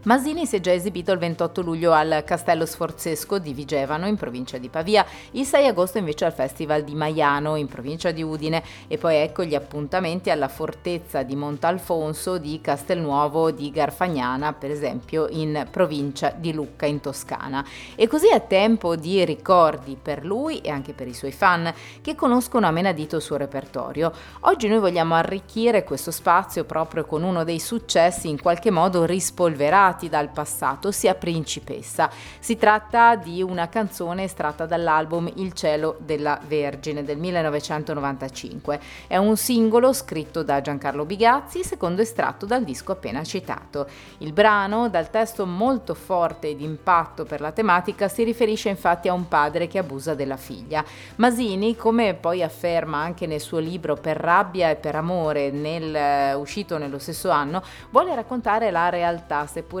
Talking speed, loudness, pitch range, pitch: 160 wpm, -23 LUFS, 150-190 Hz, 165 Hz